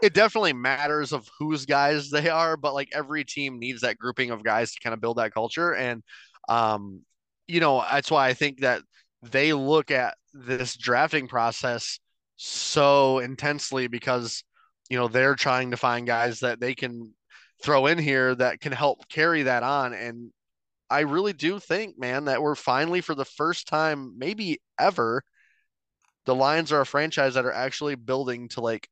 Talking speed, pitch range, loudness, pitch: 180 wpm, 120-150 Hz, -25 LUFS, 135 Hz